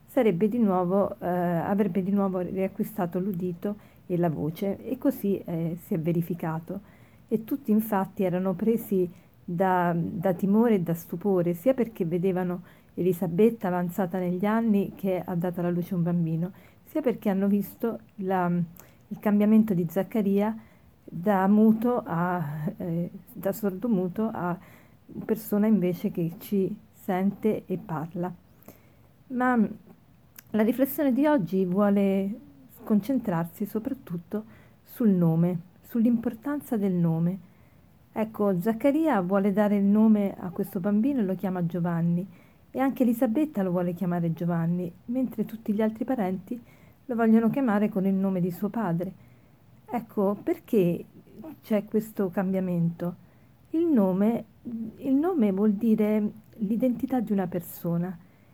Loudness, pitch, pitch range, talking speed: -27 LUFS, 200 Hz, 180-220 Hz, 130 wpm